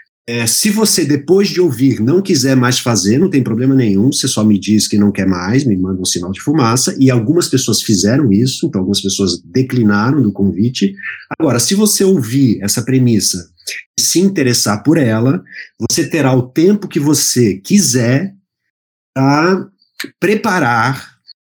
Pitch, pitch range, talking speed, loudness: 125 Hz, 105-155 Hz, 165 wpm, -13 LUFS